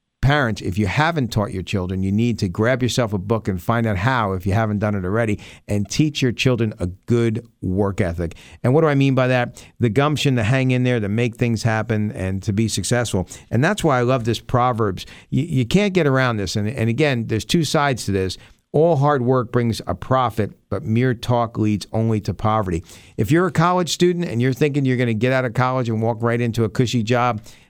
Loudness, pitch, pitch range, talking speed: -20 LUFS, 115 Hz, 105-130 Hz, 235 wpm